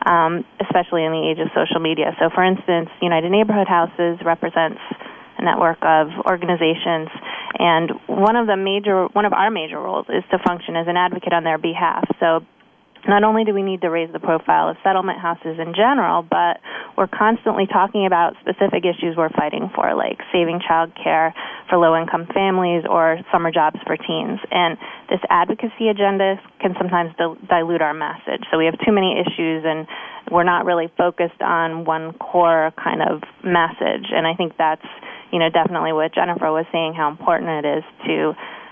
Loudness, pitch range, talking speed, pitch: -19 LUFS, 165-185 Hz, 180 wpm, 170 Hz